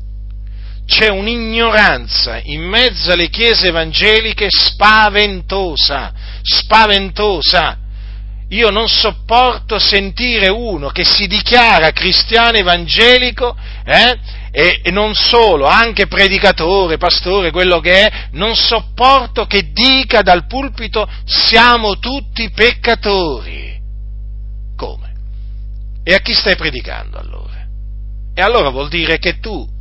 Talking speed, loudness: 105 wpm, -10 LUFS